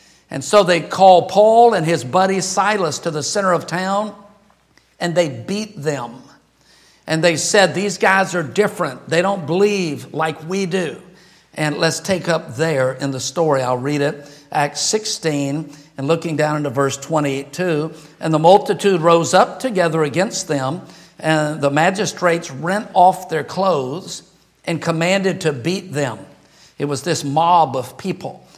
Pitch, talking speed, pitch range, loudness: 170 Hz, 160 wpm, 150-190 Hz, -17 LUFS